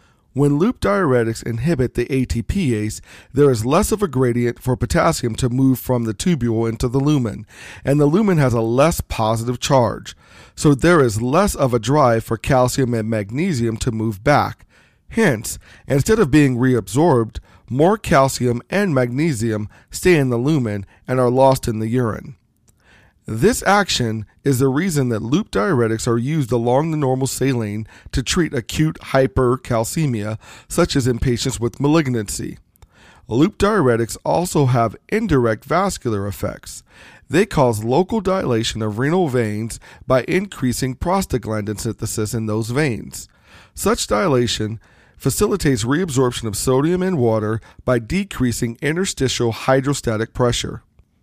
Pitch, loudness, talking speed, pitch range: 125 Hz, -18 LUFS, 140 wpm, 115-145 Hz